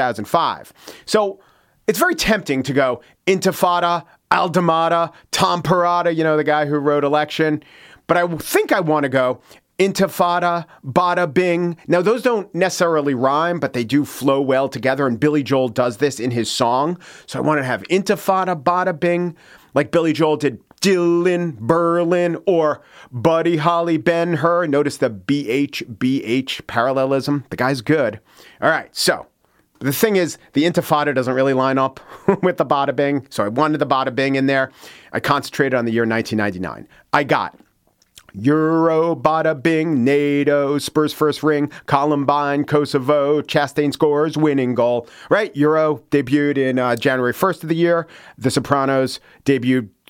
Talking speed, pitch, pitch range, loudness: 160 wpm, 150 Hz, 135-170 Hz, -18 LUFS